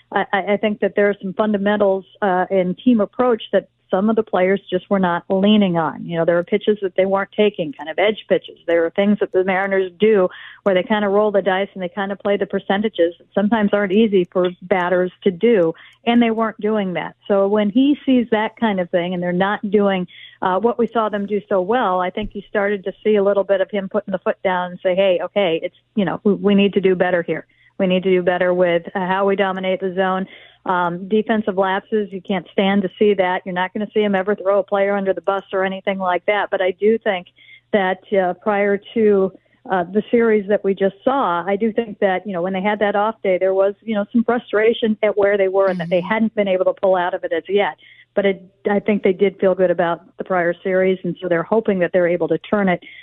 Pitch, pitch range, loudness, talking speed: 195 Hz, 185-210 Hz, -18 LUFS, 255 wpm